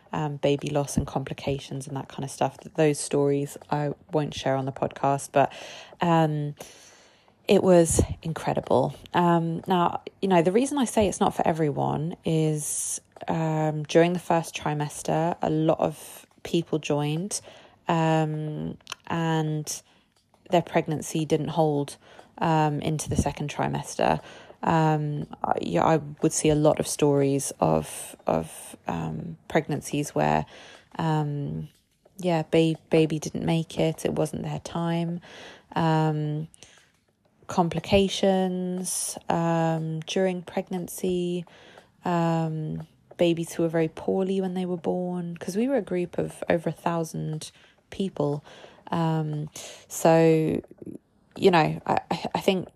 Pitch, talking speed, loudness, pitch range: 160 Hz, 130 wpm, -26 LUFS, 145-170 Hz